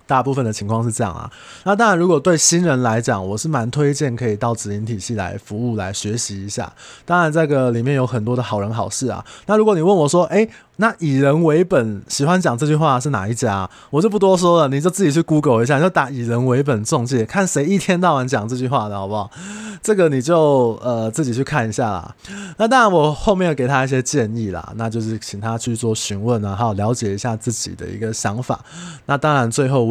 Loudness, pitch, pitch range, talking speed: -18 LUFS, 130 Hz, 115-160 Hz, 350 characters per minute